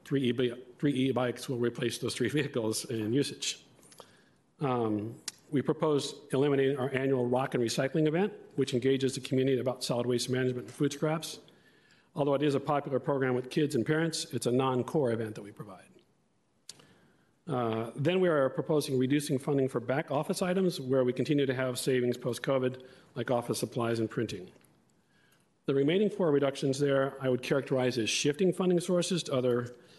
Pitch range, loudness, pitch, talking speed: 125-145 Hz, -30 LUFS, 135 Hz, 175 wpm